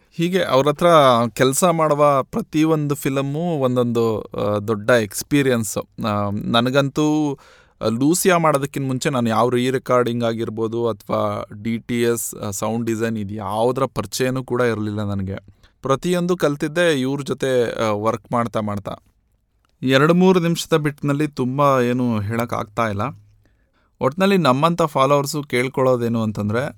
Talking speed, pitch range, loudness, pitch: 115 wpm, 110-145 Hz, -19 LUFS, 125 Hz